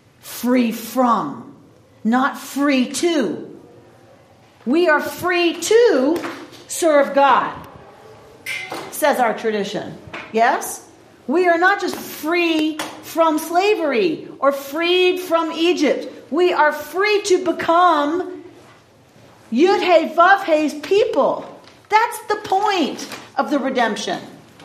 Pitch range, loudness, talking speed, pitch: 280-355 Hz, -18 LUFS, 95 wpm, 325 Hz